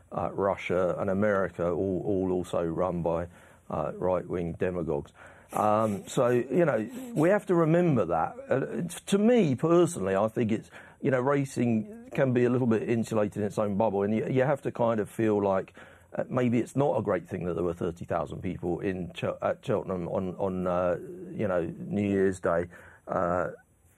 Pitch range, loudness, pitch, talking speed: 95-130 Hz, -28 LUFS, 110 Hz, 190 wpm